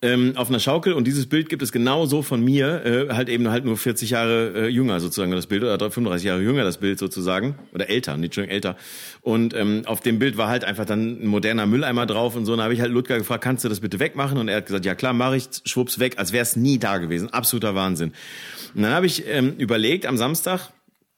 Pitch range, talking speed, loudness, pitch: 105-130 Hz, 250 wpm, -22 LUFS, 120 Hz